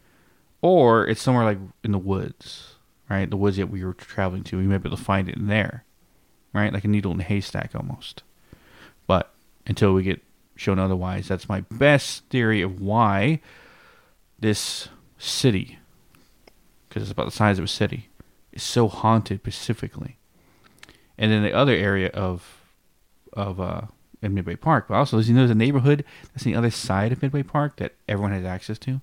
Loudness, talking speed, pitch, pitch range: -23 LUFS, 185 wpm, 105 Hz, 95-120 Hz